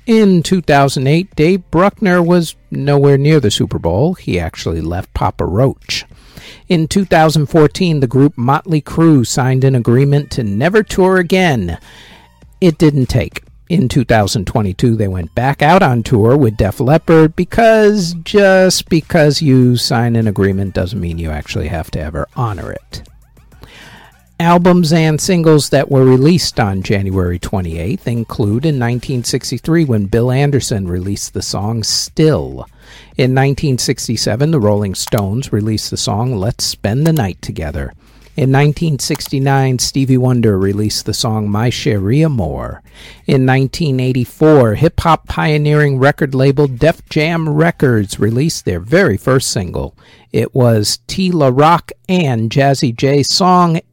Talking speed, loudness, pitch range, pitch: 140 wpm, -13 LUFS, 110-155 Hz, 135 Hz